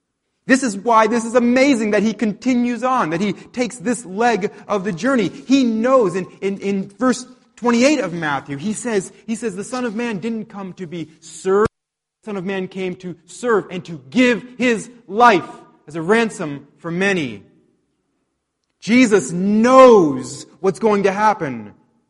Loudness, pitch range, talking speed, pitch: -17 LUFS, 185-240 Hz, 170 wpm, 210 Hz